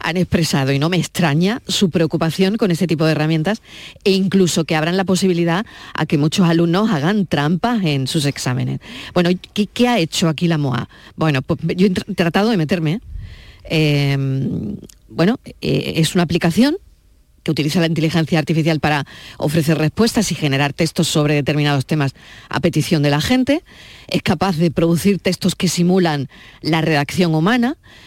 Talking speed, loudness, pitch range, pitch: 170 wpm, -17 LUFS, 155-190 Hz, 170 Hz